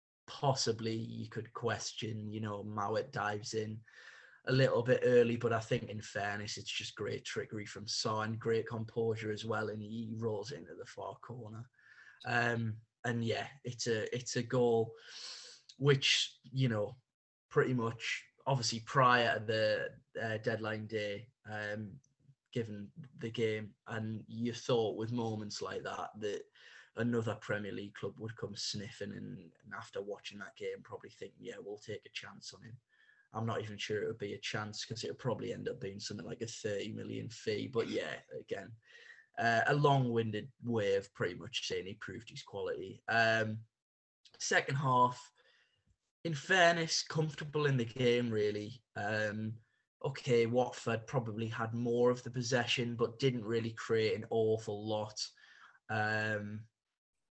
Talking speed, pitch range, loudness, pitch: 160 wpm, 110-125 Hz, -36 LUFS, 115 Hz